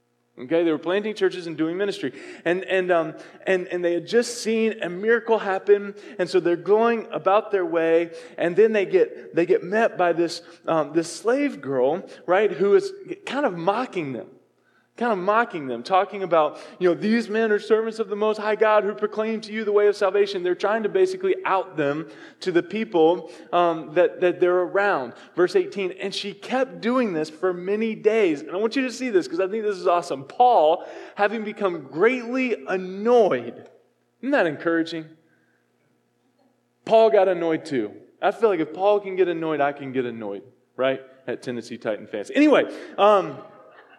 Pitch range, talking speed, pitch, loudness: 170-225 Hz, 190 wpm, 195 Hz, -22 LUFS